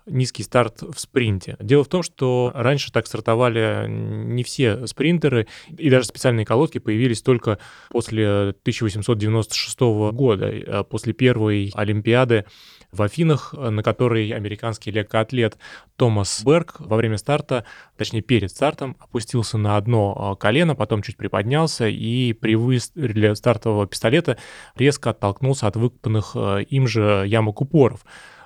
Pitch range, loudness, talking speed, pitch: 105-130 Hz, -21 LUFS, 125 wpm, 115 Hz